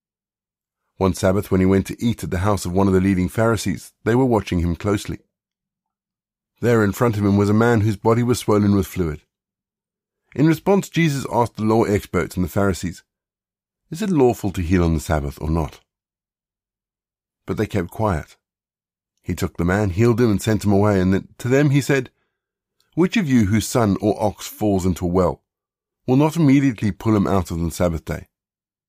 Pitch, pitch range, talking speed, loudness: 100 Hz, 95-115 Hz, 195 wpm, -19 LUFS